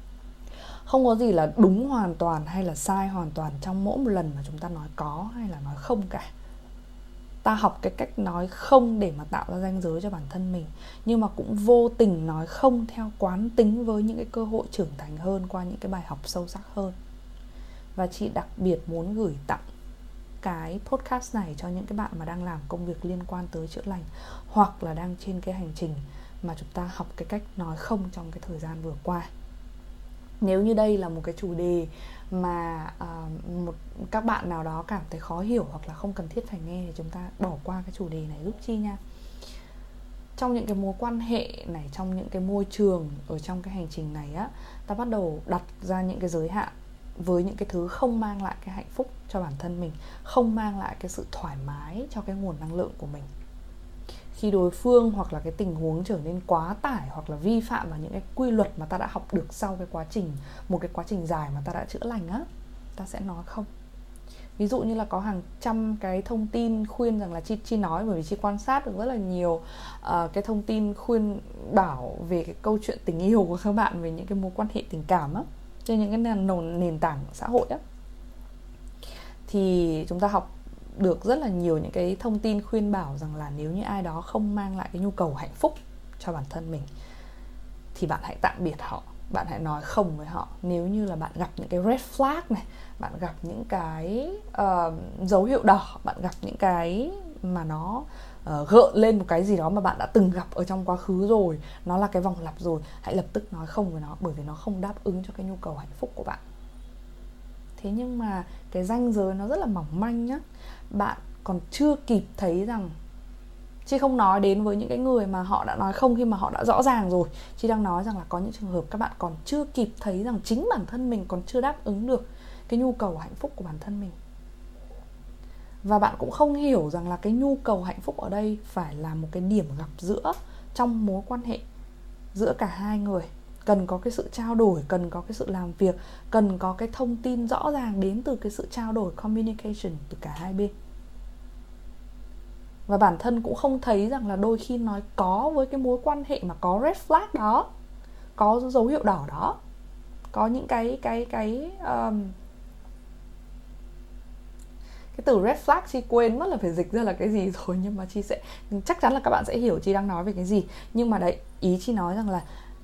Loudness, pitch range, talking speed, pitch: -27 LUFS, 170-220 Hz, 230 wpm, 195 Hz